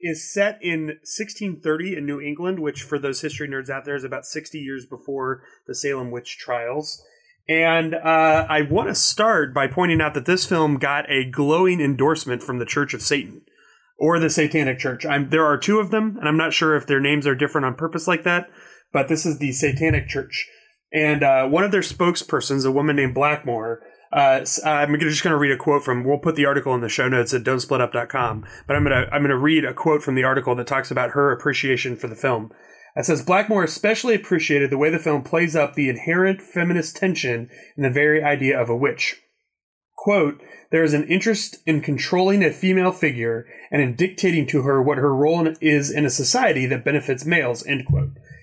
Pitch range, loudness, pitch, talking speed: 135-165 Hz, -20 LUFS, 150 Hz, 215 wpm